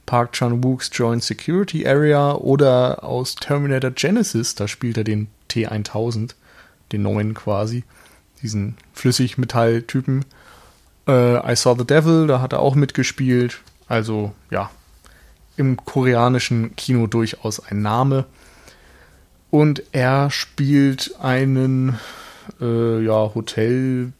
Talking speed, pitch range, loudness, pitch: 110 wpm, 110-135 Hz, -19 LUFS, 125 Hz